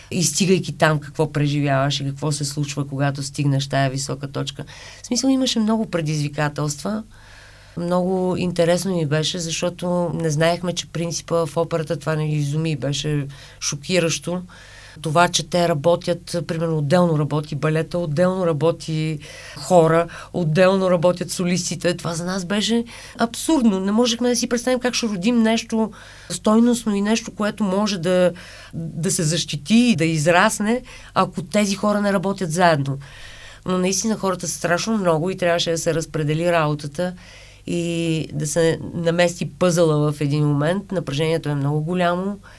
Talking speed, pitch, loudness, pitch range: 150 wpm, 170 Hz, -20 LUFS, 155-185 Hz